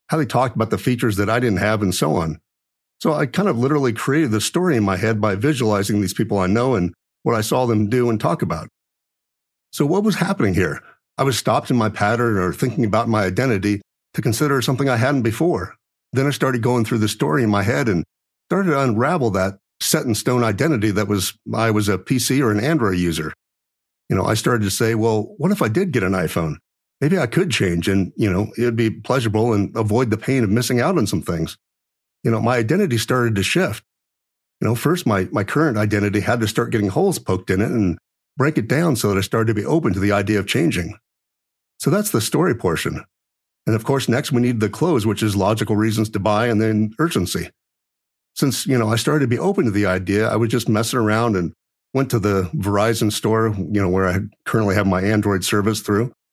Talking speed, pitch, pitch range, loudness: 230 wpm, 110 Hz, 105-125 Hz, -19 LUFS